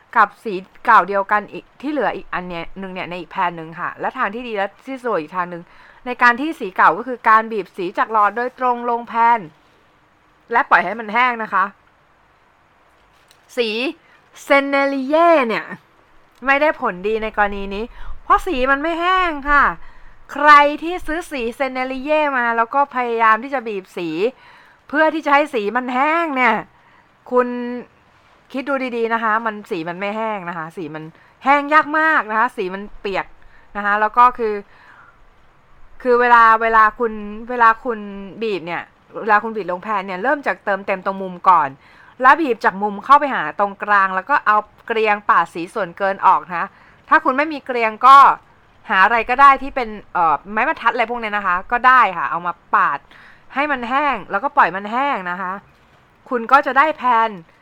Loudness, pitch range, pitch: -17 LUFS, 205-275 Hz, 235 Hz